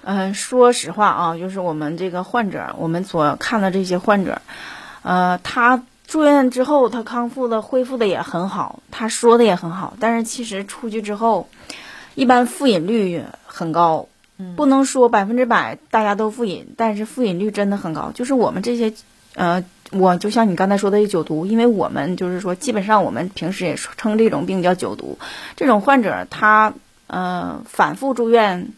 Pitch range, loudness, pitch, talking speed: 185-240 Hz, -18 LUFS, 215 Hz, 275 characters per minute